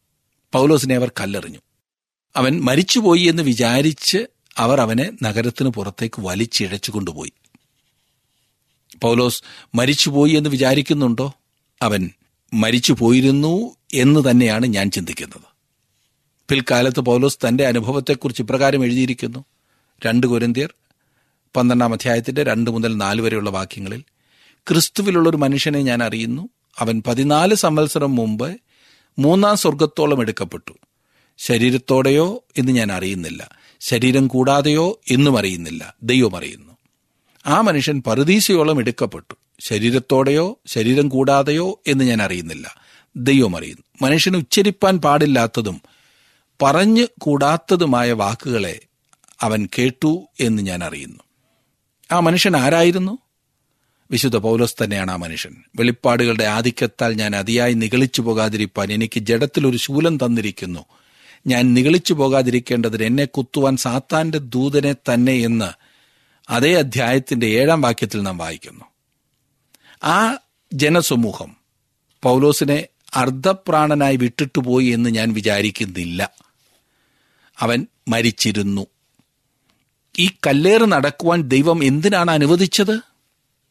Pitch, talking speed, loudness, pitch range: 130 Hz, 95 wpm, -17 LUFS, 115-150 Hz